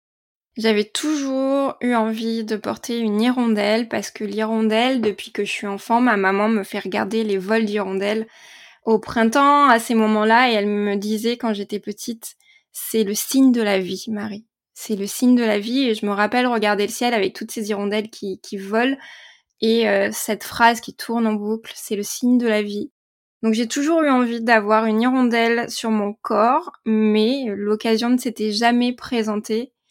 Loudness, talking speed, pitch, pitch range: -20 LUFS, 190 wpm, 225 Hz, 210-240 Hz